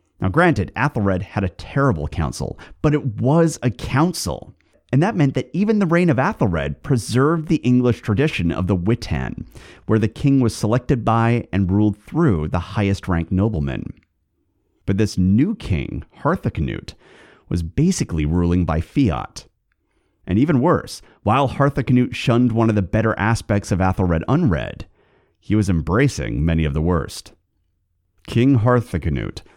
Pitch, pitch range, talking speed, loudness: 110 Hz, 90-130 Hz, 150 wpm, -19 LUFS